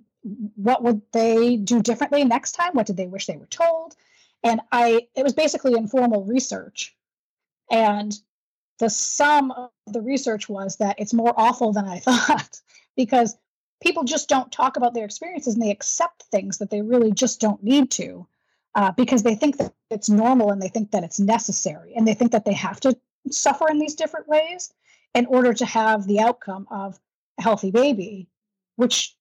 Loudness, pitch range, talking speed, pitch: -21 LUFS, 210-260 Hz, 185 wpm, 235 Hz